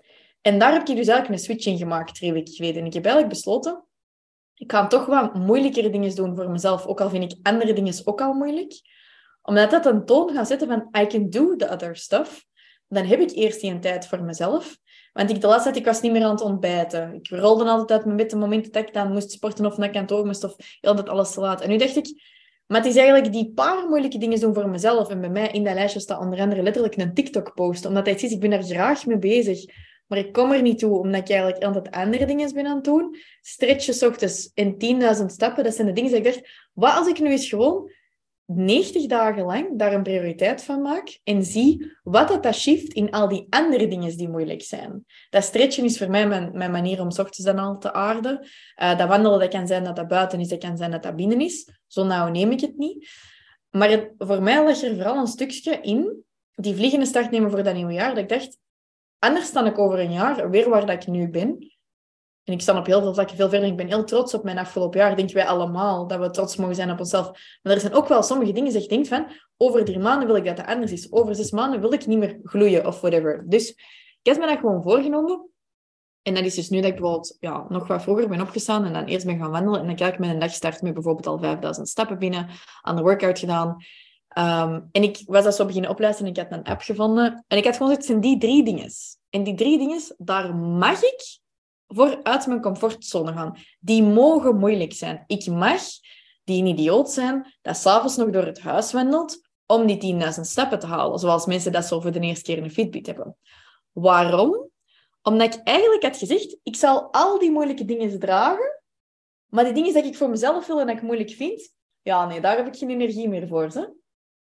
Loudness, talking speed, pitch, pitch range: -21 LUFS, 240 wpm, 210 Hz, 185-255 Hz